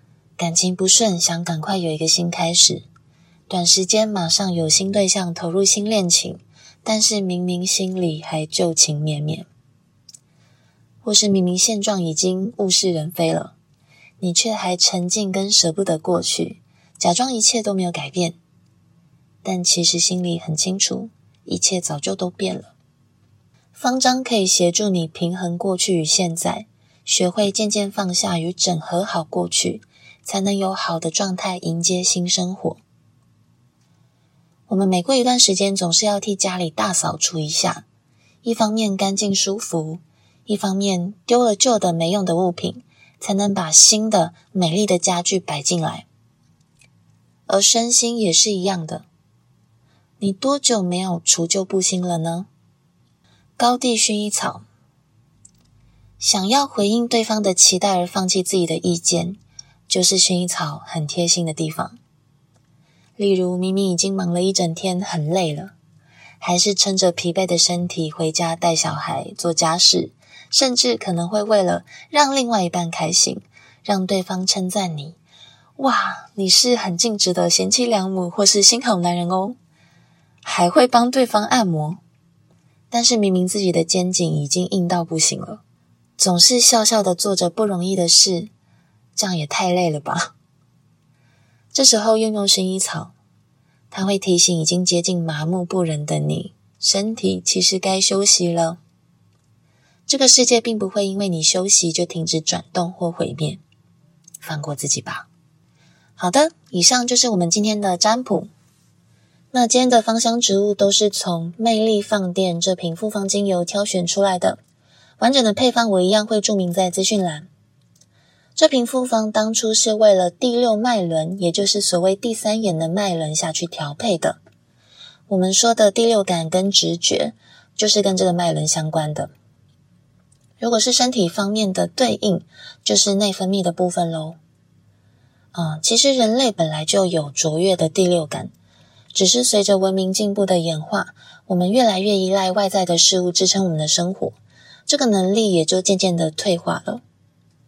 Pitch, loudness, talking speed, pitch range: 185 Hz, -17 LUFS, 230 characters per minute, 165-205 Hz